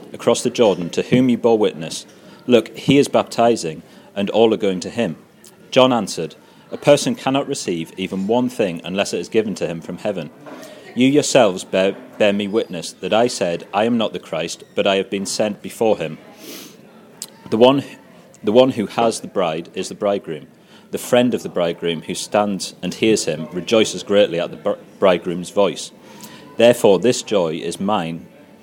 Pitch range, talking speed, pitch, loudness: 95-125 Hz, 185 wpm, 105 Hz, -18 LUFS